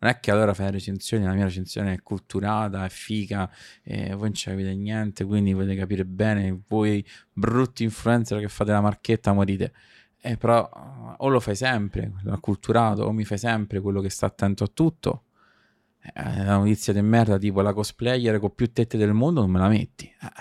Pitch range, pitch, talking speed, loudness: 100-110 Hz, 105 Hz, 205 wpm, -24 LUFS